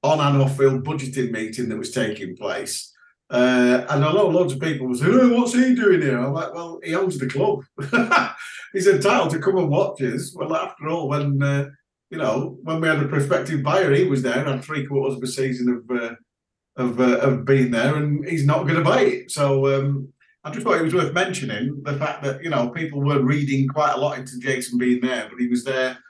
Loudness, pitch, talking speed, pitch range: -21 LUFS, 140 Hz, 235 wpm, 130-160 Hz